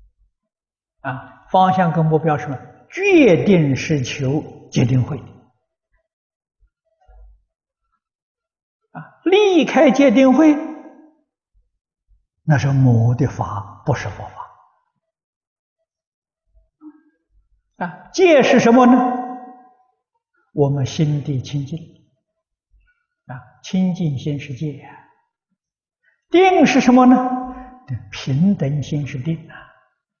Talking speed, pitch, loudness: 115 characters per minute, 215 Hz, -16 LUFS